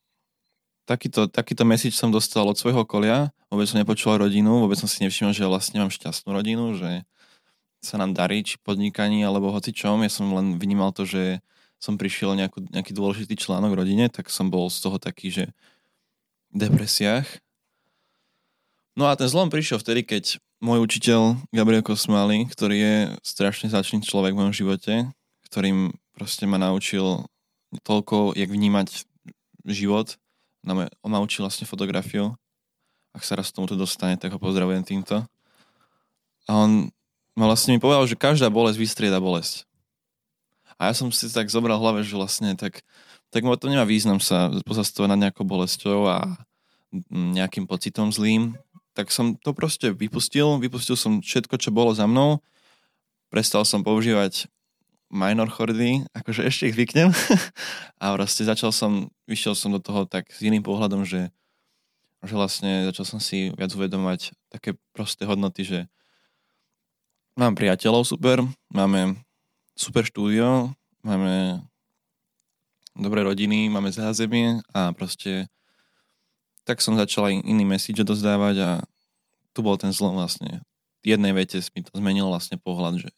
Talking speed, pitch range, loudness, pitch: 155 wpm, 95-115 Hz, -23 LUFS, 105 Hz